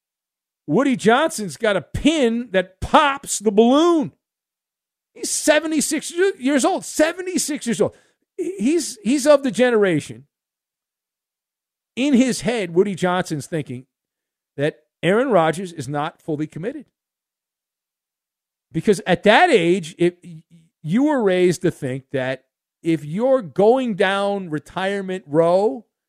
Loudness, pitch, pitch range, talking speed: -19 LUFS, 200 Hz, 165-265 Hz, 115 wpm